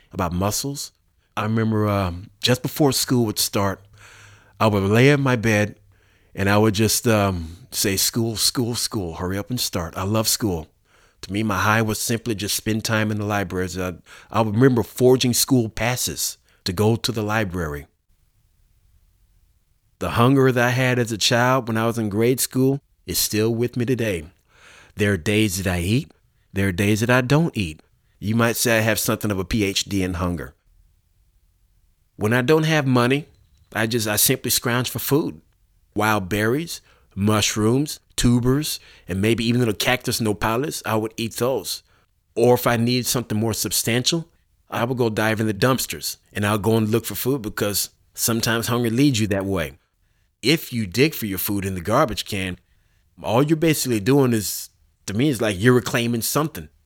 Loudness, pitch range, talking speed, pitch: -21 LUFS, 95-120 Hz, 185 wpm, 110 Hz